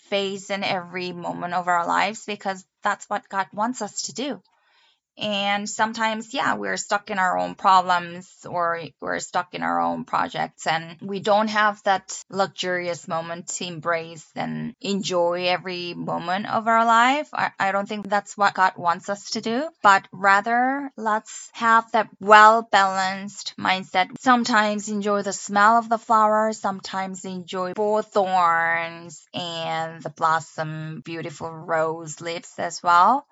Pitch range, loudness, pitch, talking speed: 170-210 Hz, -22 LUFS, 195 Hz, 150 wpm